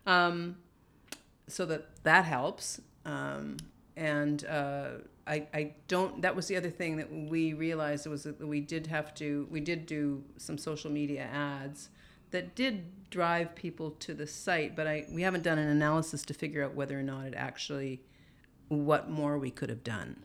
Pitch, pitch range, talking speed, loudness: 150 Hz, 145-165 Hz, 180 wpm, -34 LUFS